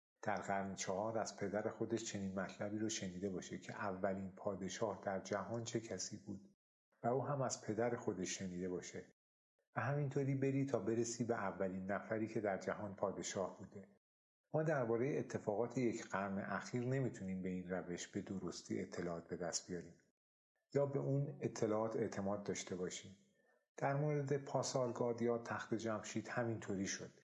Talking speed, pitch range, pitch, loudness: 155 wpm, 95-120 Hz, 105 Hz, -42 LUFS